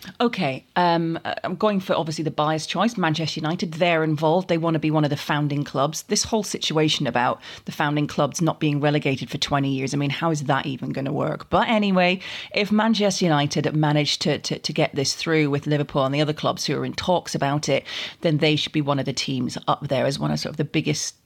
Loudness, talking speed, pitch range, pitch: -22 LUFS, 235 wpm, 145-170 Hz, 155 Hz